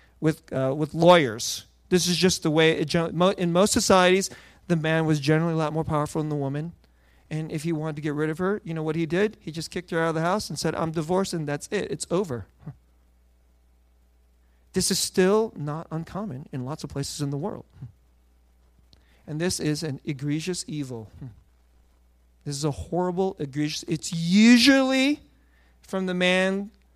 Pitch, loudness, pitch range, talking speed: 155 Hz, -24 LUFS, 130-180 Hz, 190 wpm